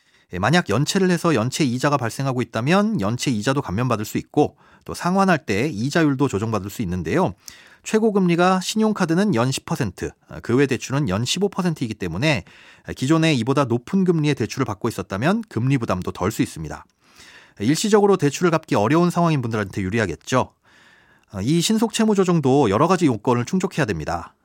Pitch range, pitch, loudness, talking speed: 115-180 Hz, 145 Hz, -20 LUFS, 365 characters per minute